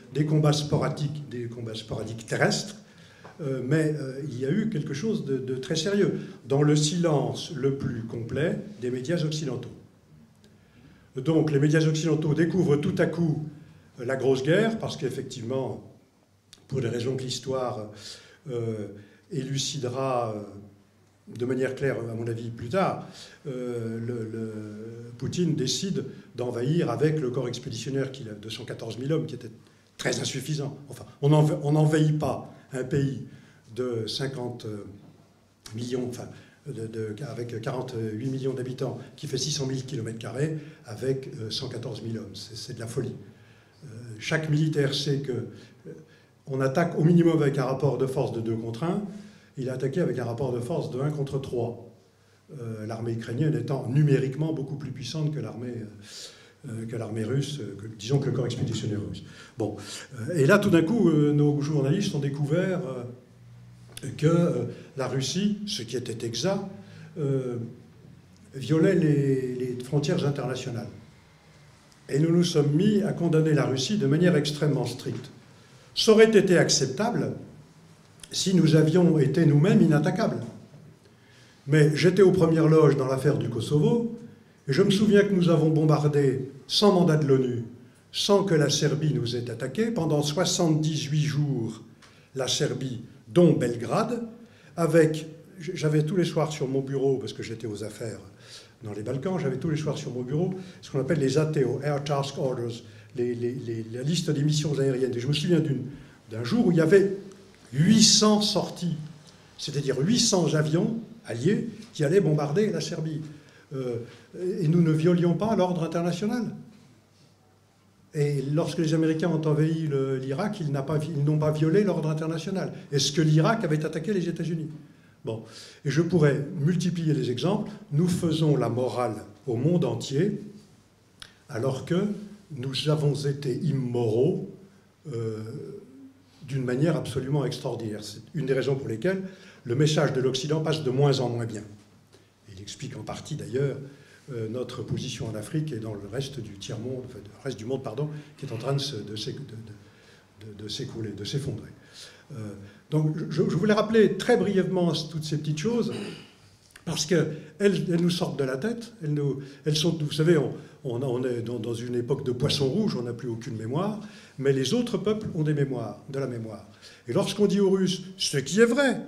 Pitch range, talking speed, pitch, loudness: 120-160 Hz, 170 wpm, 140 Hz, -26 LUFS